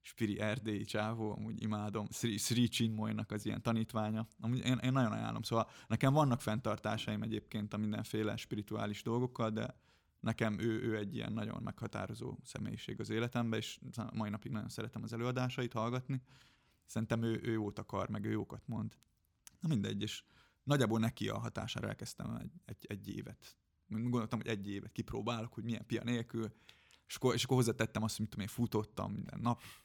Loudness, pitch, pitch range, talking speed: -38 LUFS, 110 Hz, 110-120 Hz, 170 wpm